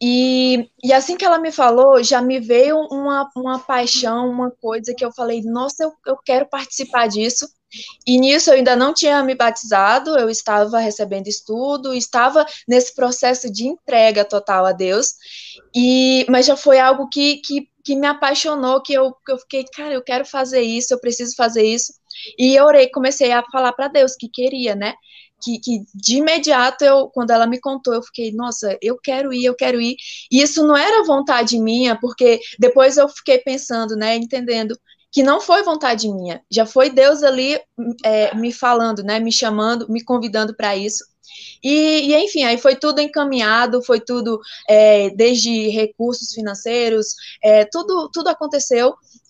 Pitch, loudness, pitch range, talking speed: 250 Hz, -16 LUFS, 230-275 Hz, 175 wpm